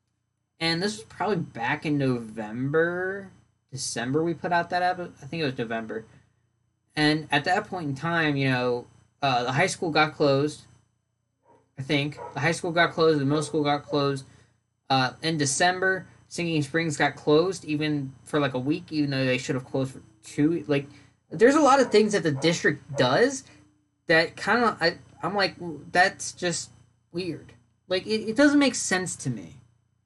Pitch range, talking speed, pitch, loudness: 125-170 Hz, 180 wpm, 150 Hz, -25 LUFS